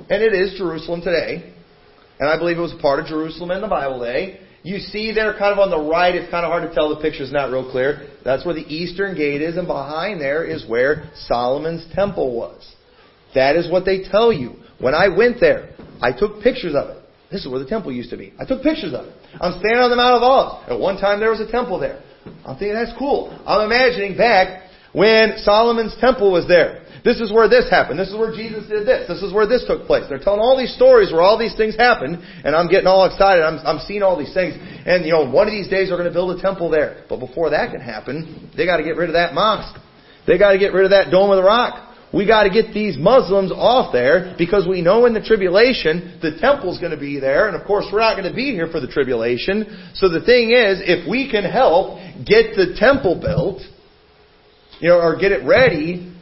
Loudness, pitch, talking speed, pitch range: -17 LUFS, 190 Hz, 240 wpm, 165-220 Hz